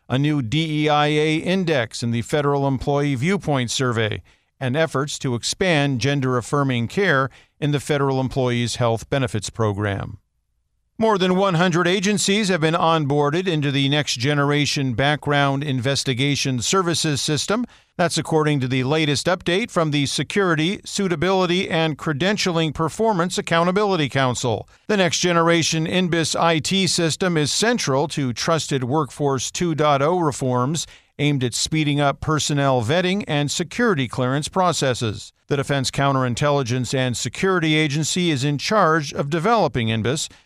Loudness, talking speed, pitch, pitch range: -20 LUFS, 130 wpm, 150 Hz, 130-170 Hz